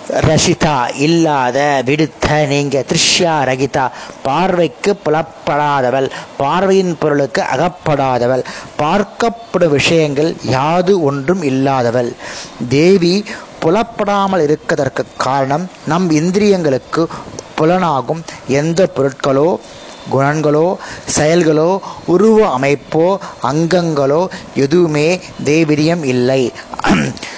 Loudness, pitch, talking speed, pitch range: -14 LUFS, 155 Hz, 70 wpm, 140-180 Hz